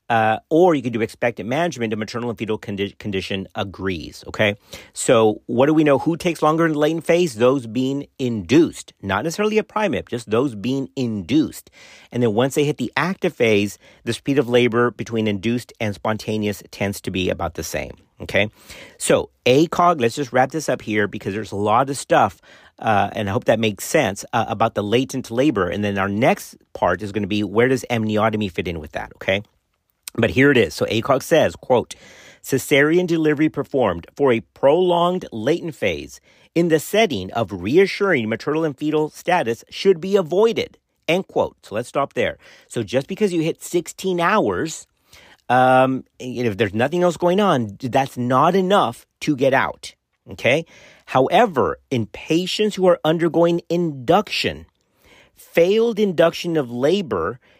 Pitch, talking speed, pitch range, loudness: 130 Hz, 175 wpm, 110-170 Hz, -20 LUFS